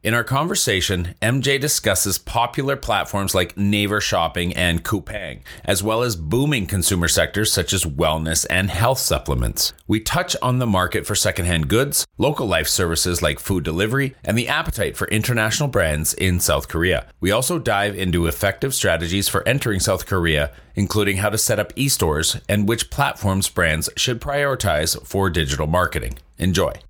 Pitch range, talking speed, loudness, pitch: 85-115 Hz, 165 wpm, -20 LUFS, 100 Hz